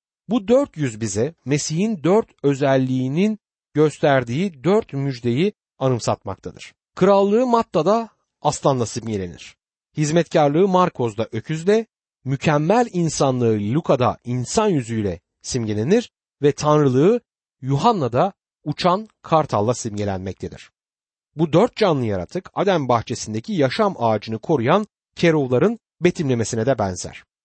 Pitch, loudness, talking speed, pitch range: 145 Hz, -20 LUFS, 95 wpm, 120-185 Hz